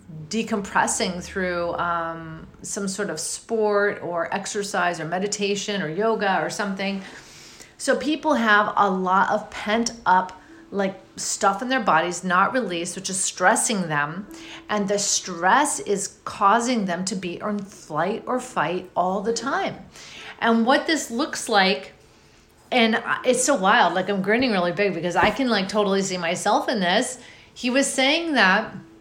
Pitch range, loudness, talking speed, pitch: 185-230 Hz, -22 LUFS, 155 wpm, 205 Hz